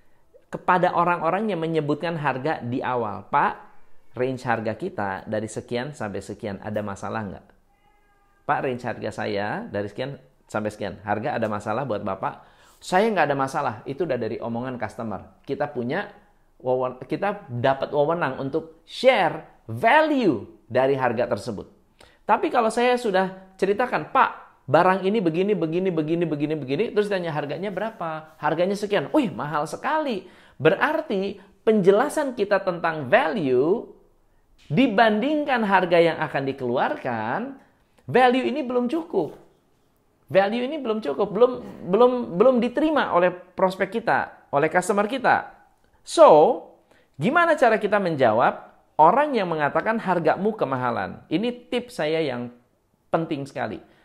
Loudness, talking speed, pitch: -23 LUFS, 130 wpm, 175 Hz